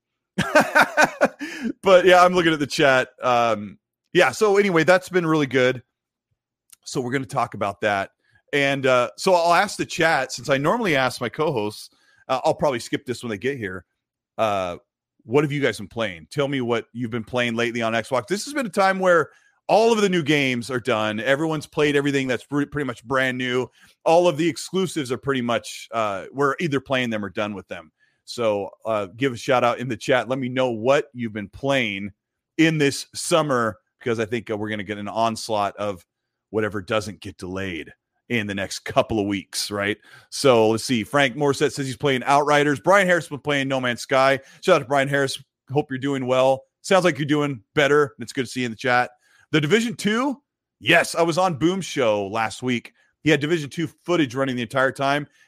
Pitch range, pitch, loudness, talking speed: 115-155 Hz, 135 Hz, -21 LUFS, 215 wpm